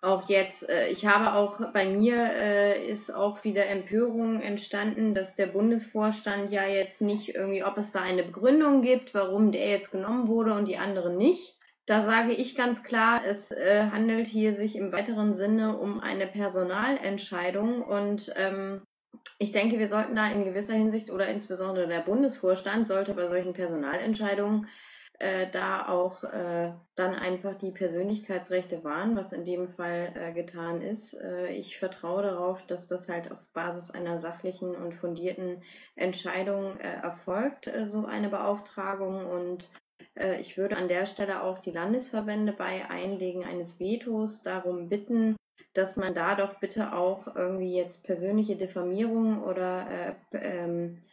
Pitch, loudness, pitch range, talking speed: 195 Hz, -29 LUFS, 185-215 Hz, 155 wpm